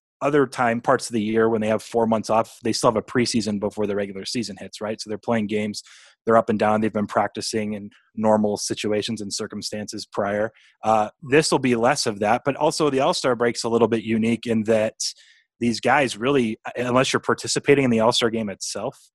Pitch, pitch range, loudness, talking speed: 115 Hz, 105-120 Hz, -22 LUFS, 220 wpm